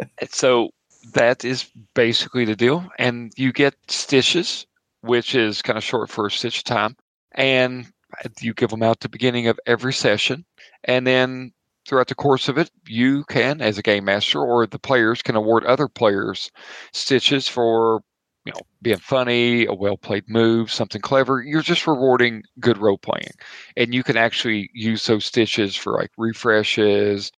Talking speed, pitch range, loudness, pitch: 170 wpm, 115-130 Hz, -20 LUFS, 120 Hz